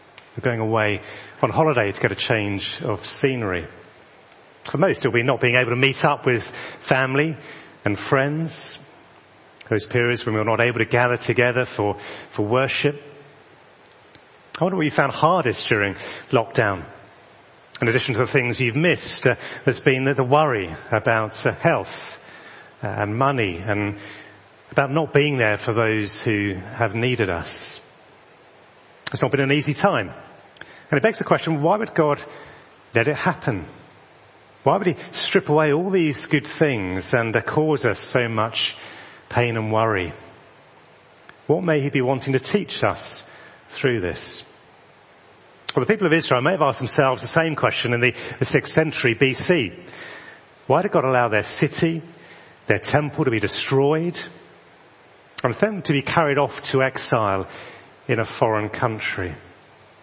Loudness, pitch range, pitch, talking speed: -21 LUFS, 110-150 Hz, 130 Hz, 160 wpm